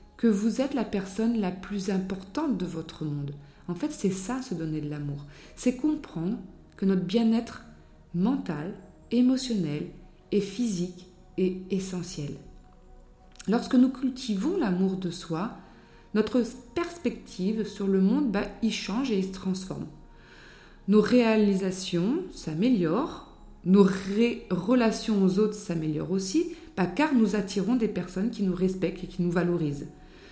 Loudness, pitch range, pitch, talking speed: -28 LUFS, 180-230 Hz, 195 Hz, 140 wpm